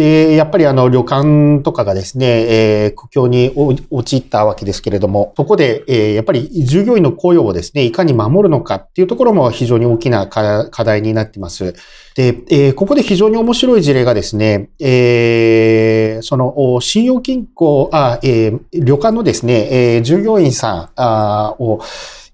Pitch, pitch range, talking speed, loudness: 125 Hz, 110-155 Hz, 295 characters per minute, -12 LUFS